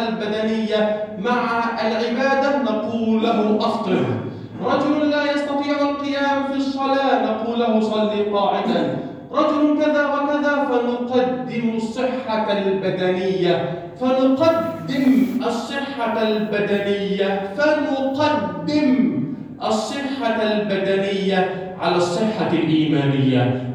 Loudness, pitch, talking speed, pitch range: -20 LUFS, 225 Hz, 80 wpm, 200-275 Hz